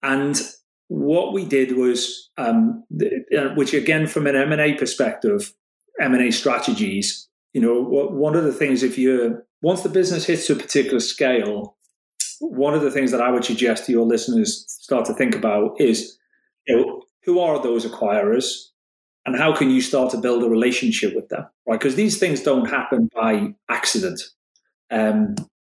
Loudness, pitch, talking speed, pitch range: -20 LUFS, 140 Hz, 165 wpm, 125-205 Hz